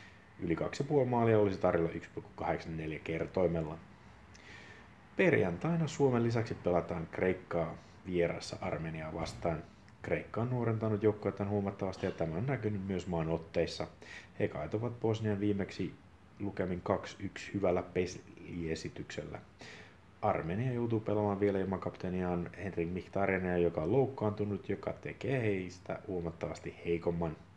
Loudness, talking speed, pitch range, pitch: -35 LUFS, 110 wpm, 85-105 Hz, 95 Hz